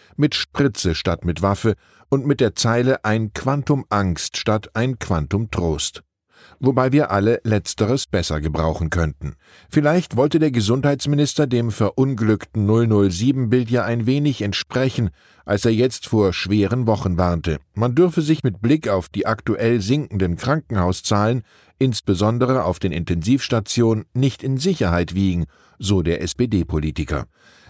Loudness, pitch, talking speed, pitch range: -20 LUFS, 110 Hz, 135 wpm, 95-130 Hz